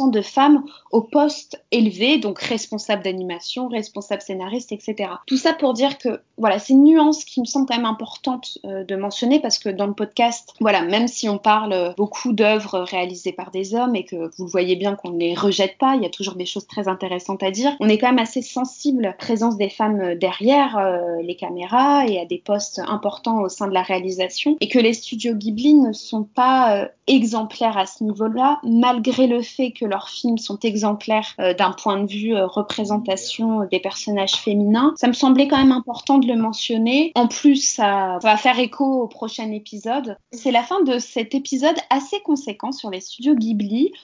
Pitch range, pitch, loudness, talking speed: 200-255 Hz, 225 Hz, -19 LUFS, 210 wpm